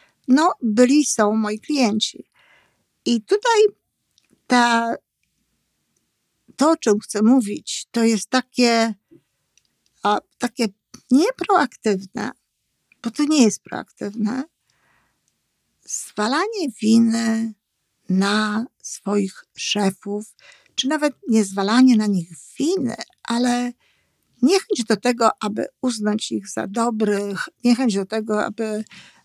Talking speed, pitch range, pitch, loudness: 100 wpm, 210-255 Hz, 230 Hz, -20 LUFS